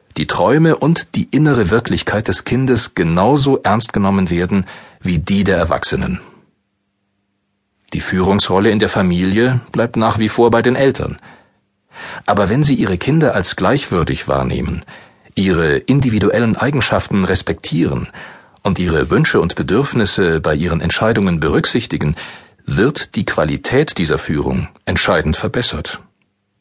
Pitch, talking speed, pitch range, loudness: 105 Hz, 125 wpm, 100-125 Hz, -15 LUFS